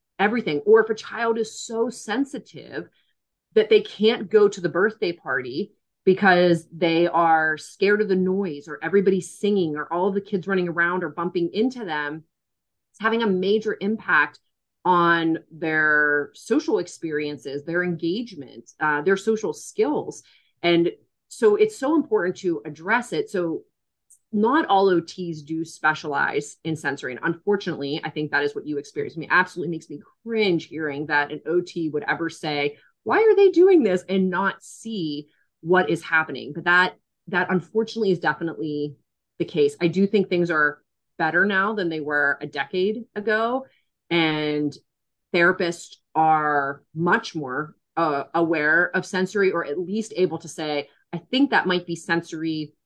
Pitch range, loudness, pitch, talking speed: 155-200 Hz, -23 LUFS, 170 Hz, 165 wpm